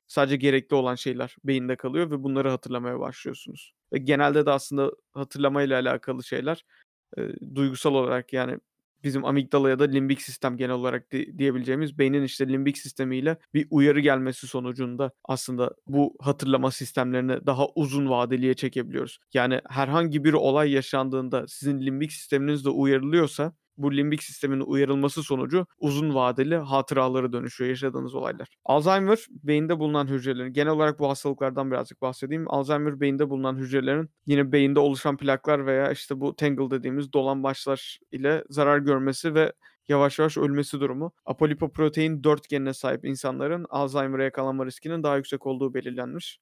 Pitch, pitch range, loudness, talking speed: 140 Hz, 135-145 Hz, -25 LUFS, 140 wpm